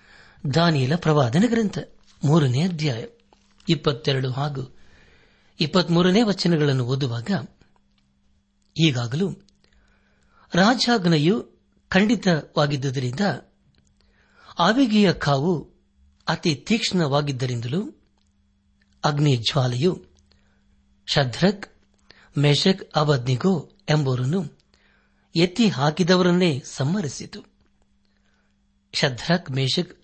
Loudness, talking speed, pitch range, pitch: -22 LUFS, 50 wpm, 125-180 Hz, 150 Hz